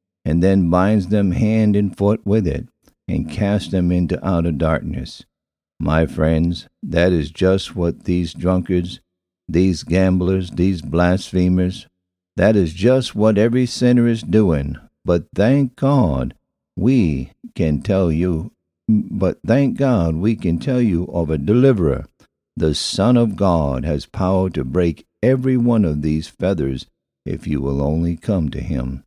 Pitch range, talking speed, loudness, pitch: 80-105 Hz, 150 wpm, -18 LUFS, 90 Hz